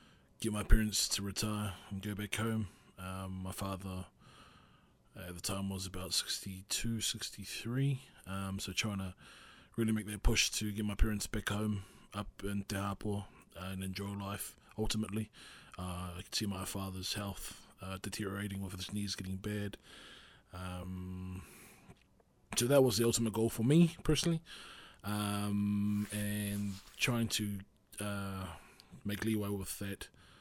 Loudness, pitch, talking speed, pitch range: -37 LUFS, 100 Hz, 145 wpm, 95-105 Hz